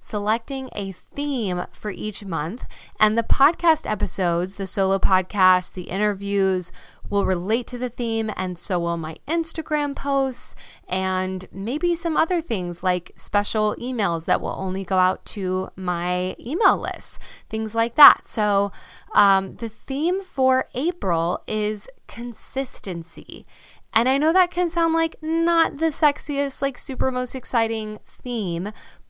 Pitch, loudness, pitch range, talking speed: 215 Hz, -23 LUFS, 185-275 Hz, 140 wpm